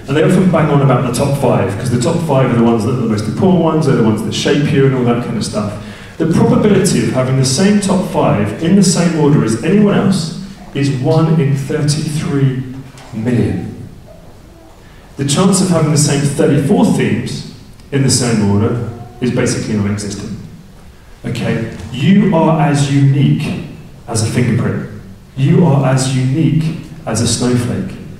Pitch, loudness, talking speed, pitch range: 140 Hz, -13 LUFS, 180 wpm, 120-160 Hz